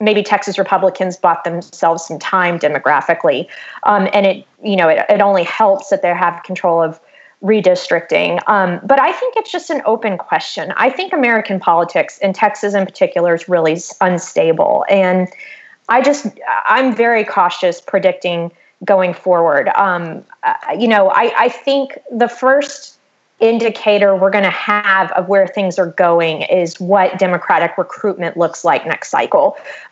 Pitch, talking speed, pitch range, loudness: 195 Hz, 155 wpm, 180-230 Hz, -14 LUFS